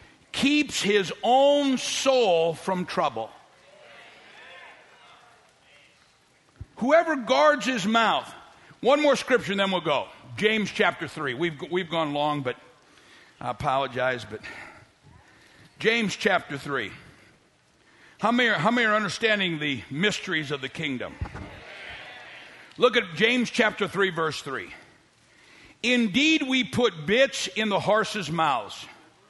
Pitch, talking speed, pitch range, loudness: 205 Hz, 120 wpm, 160-245 Hz, -24 LUFS